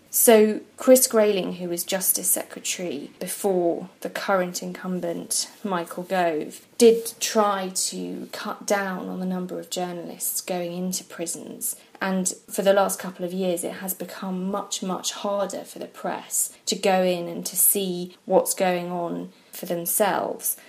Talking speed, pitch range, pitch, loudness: 155 wpm, 180-205 Hz, 185 Hz, -24 LUFS